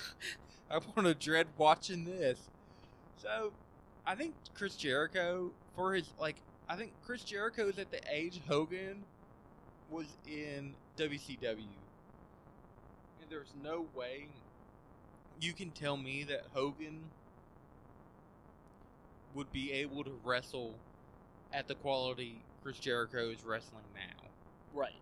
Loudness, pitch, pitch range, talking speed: -39 LUFS, 150 Hz, 130-175 Hz, 120 wpm